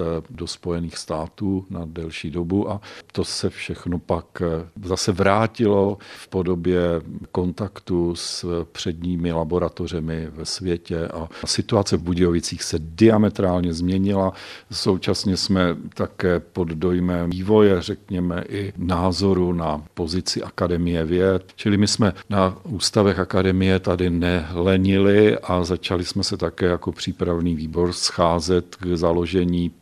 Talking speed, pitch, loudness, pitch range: 120 wpm, 90 Hz, -22 LUFS, 85-95 Hz